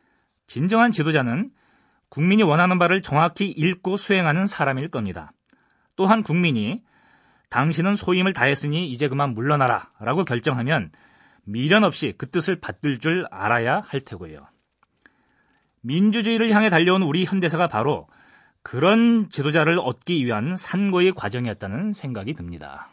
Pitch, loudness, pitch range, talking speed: 170 Hz, -21 LUFS, 135-195 Hz, 310 characters per minute